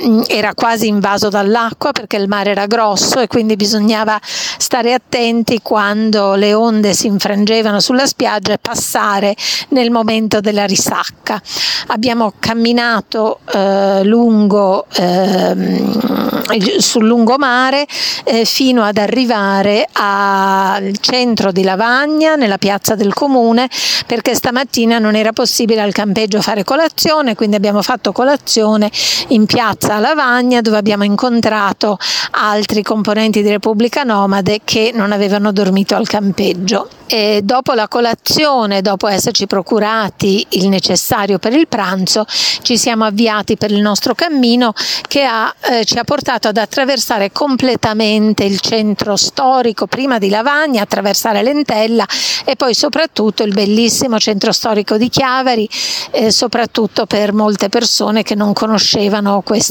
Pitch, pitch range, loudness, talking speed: 220 Hz, 205-240 Hz, -12 LUFS, 130 wpm